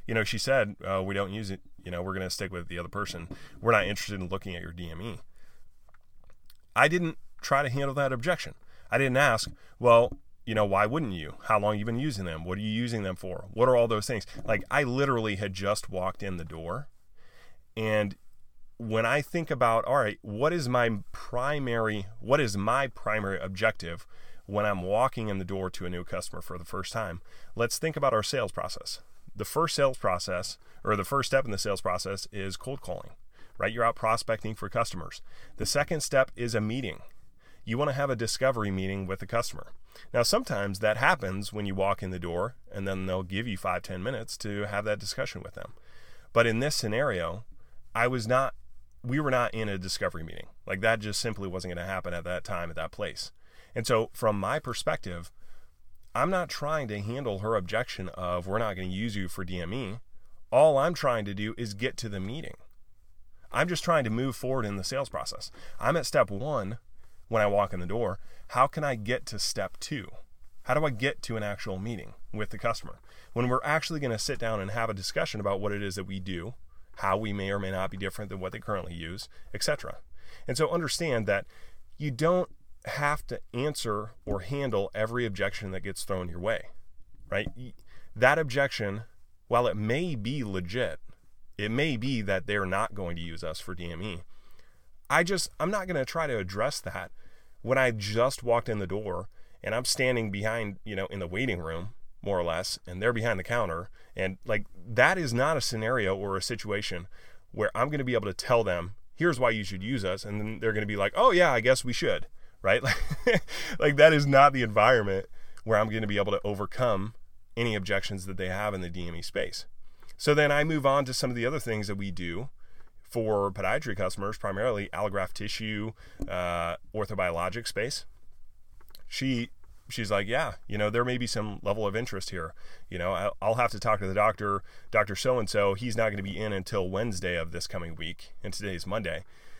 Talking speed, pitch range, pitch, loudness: 215 wpm, 95-120 Hz, 105 Hz, -29 LUFS